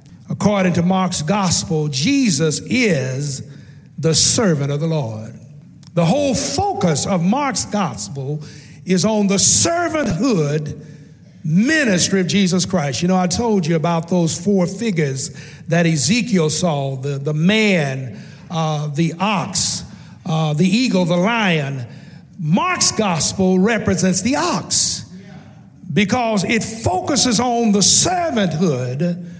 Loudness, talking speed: -17 LUFS, 120 wpm